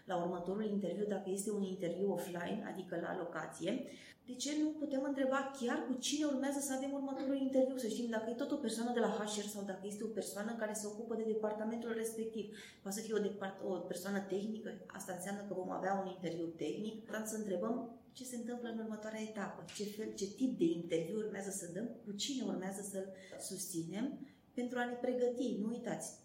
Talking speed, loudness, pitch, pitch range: 205 wpm, -40 LUFS, 215 Hz, 195-245 Hz